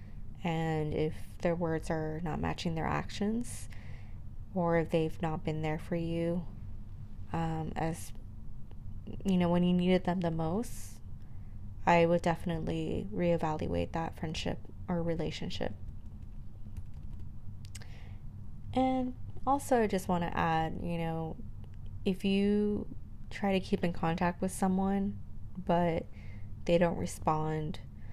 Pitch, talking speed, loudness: 155 Hz, 120 wpm, -33 LUFS